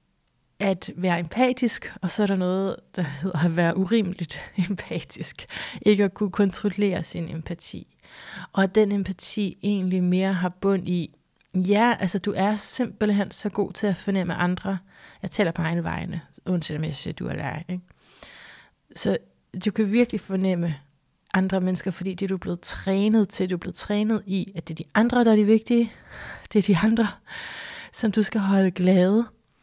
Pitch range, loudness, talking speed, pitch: 180-210 Hz, -24 LUFS, 180 wpm, 190 Hz